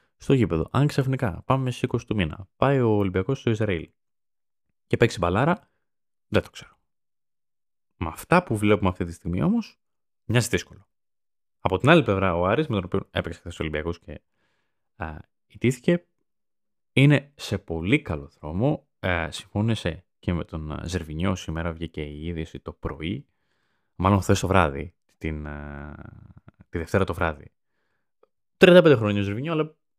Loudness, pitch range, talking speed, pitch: -24 LUFS, 85-125 Hz, 150 wpm, 95 Hz